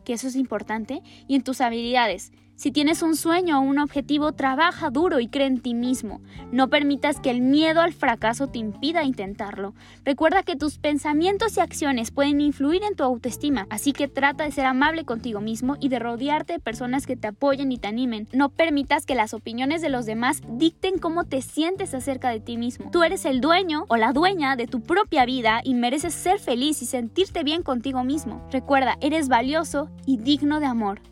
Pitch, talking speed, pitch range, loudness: 275 Hz, 200 wpm, 250-305 Hz, -23 LUFS